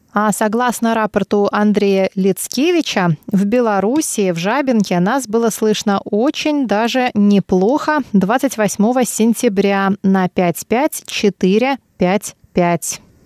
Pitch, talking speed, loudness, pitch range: 210 Hz, 110 wpm, -16 LUFS, 195-240 Hz